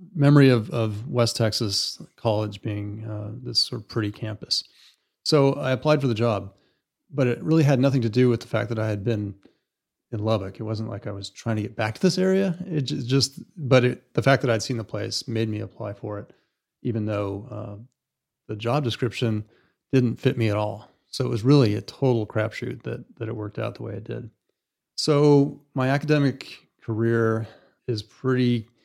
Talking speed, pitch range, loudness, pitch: 200 wpm, 110-130 Hz, -24 LUFS, 115 Hz